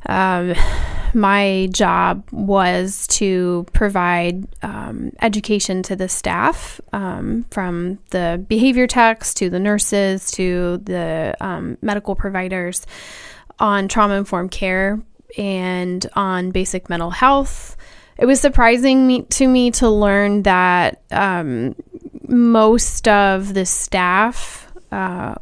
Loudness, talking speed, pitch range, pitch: -17 LUFS, 115 wpm, 185-225 Hz, 195 Hz